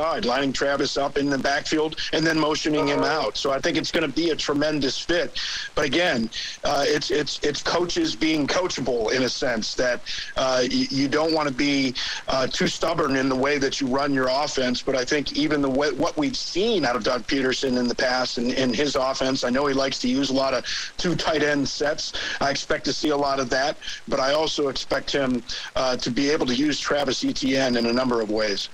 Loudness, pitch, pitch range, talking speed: -23 LUFS, 140 Hz, 130-150 Hz, 230 wpm